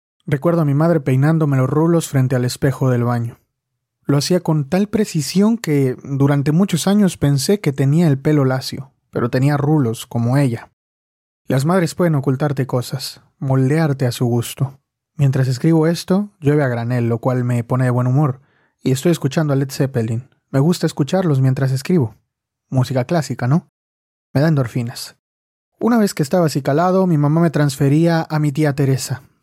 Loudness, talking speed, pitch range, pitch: -17 LUFS, 175 wpm, 125-160 Hz, 140 Hz